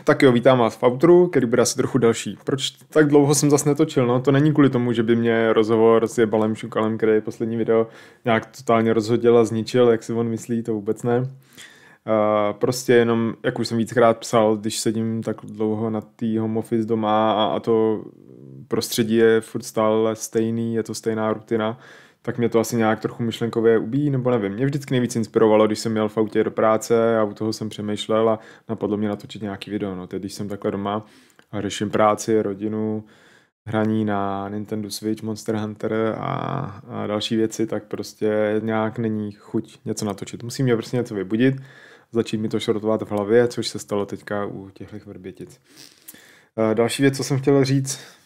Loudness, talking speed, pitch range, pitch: -21 LUFS, 190 wpm, 110-120 Hz, 110 Hz